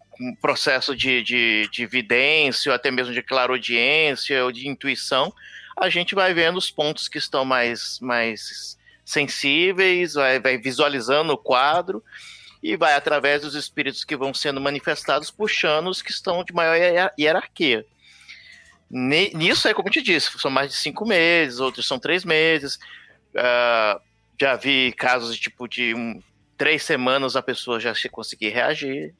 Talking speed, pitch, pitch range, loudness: 160 wpm, 140 Hz, 125-165 Hz, -20 LUFS